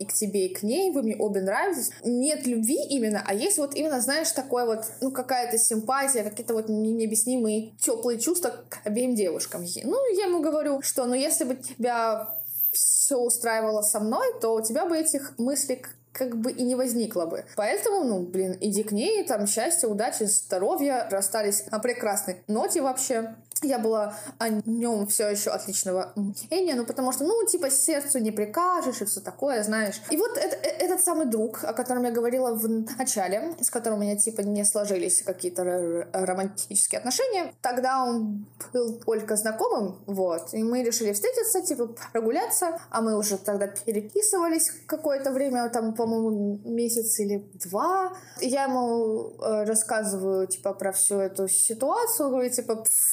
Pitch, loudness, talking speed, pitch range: 230 Hz, -25 LUFS, 170 wpm, 210-275 Hz